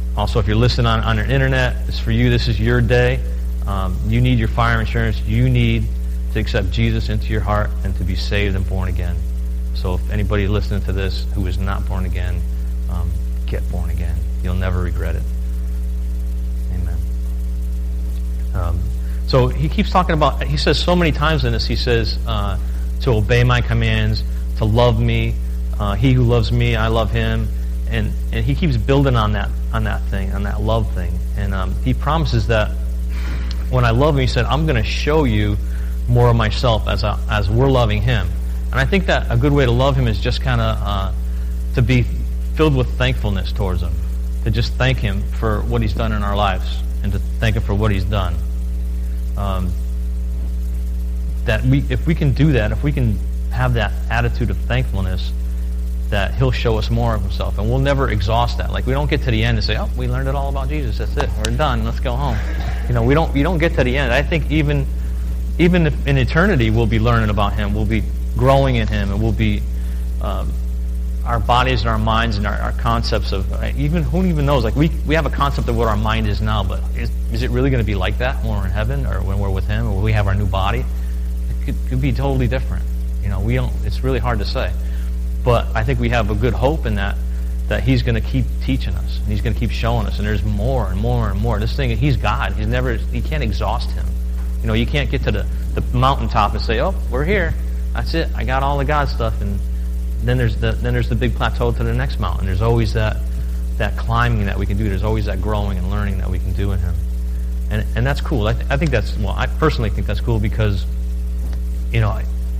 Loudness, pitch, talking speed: -19 LUFS, 85 Hz, 230 wpm